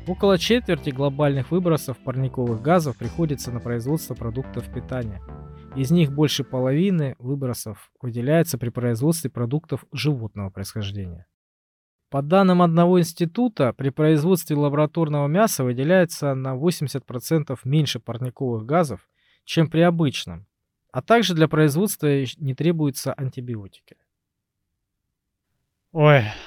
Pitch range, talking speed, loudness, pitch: 120-160 Hz, 105 wpm, -22 LUFS, 140 Hz